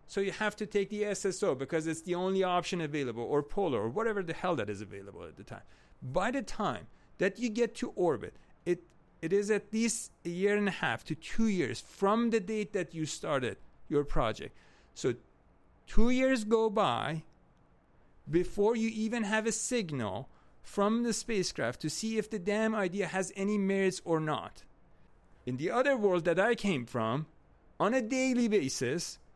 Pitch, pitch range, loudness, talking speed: 195 Hz, 155-220 Hz, -32 LUFS, 185 wpm